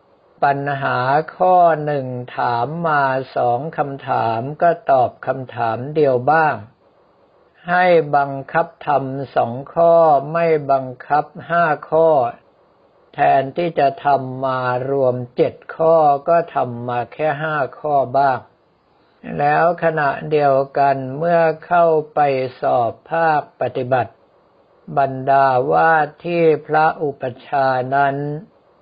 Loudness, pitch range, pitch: -17 LUFS, 130-165 Hz, 145 Hz